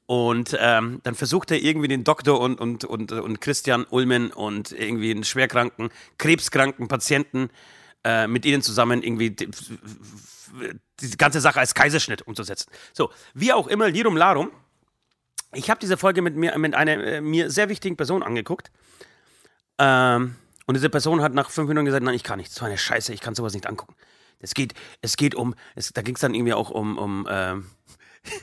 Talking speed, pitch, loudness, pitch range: 190 wpm, 125 Hz, -22 LUFS, 115-150 Hz